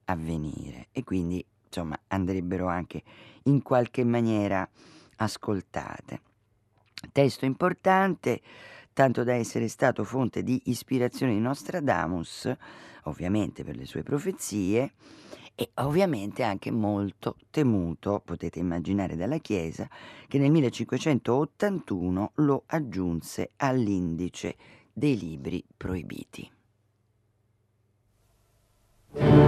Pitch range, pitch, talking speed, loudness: 95-130 Hz, 110 Hz, 90 wpm, -28 LUFS